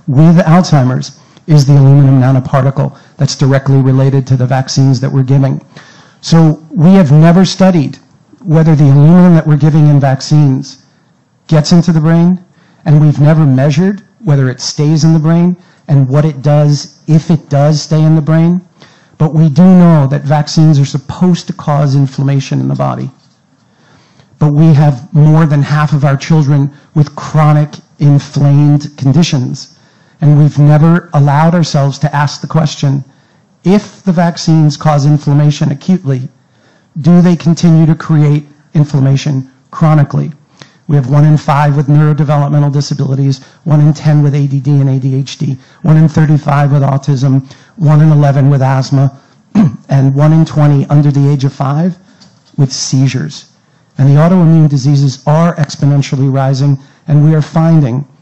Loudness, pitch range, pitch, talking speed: -9 LUFS, 140-160 Hz, 150 Hz, 155 wpm